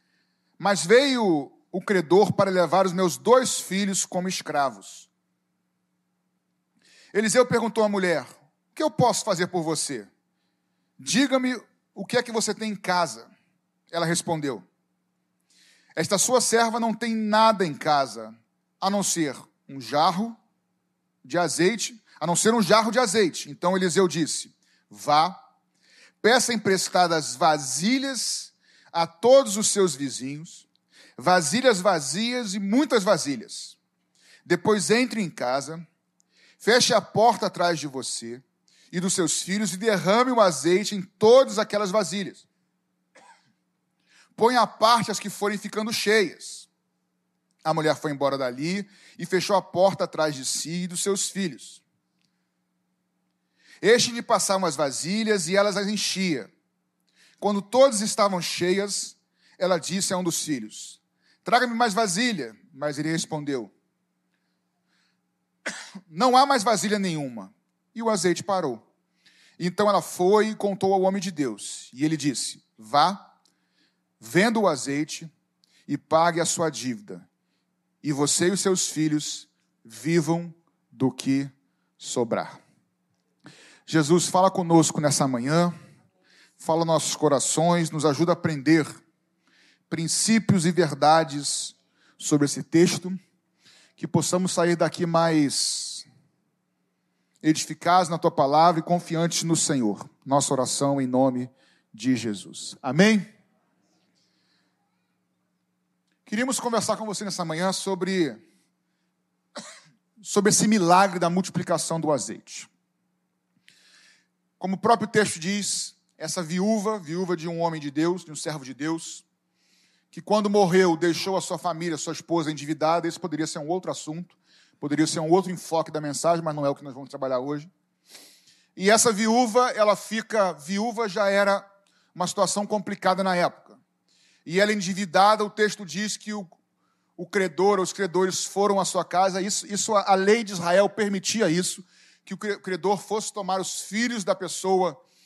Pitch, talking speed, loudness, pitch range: 180 Hz, 140 wpm, -23 LUFS, 155-205 Hz